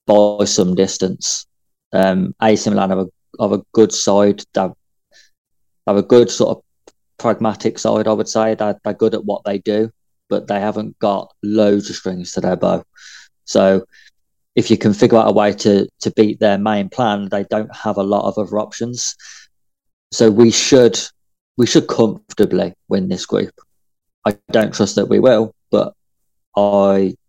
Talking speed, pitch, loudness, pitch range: 170 wpm, 105 Hz, -16 LUFS, 100-110 Hz